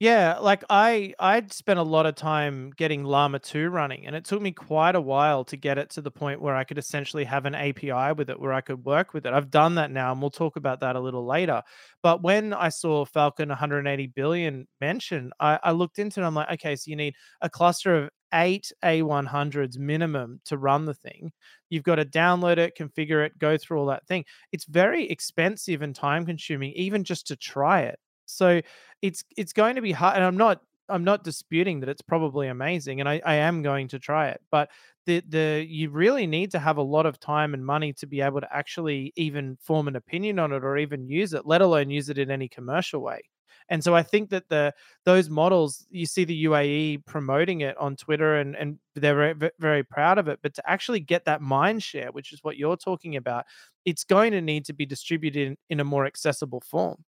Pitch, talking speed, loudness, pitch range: 155 Hz, 230 wpm, -25 LUFS, 145-175 Hz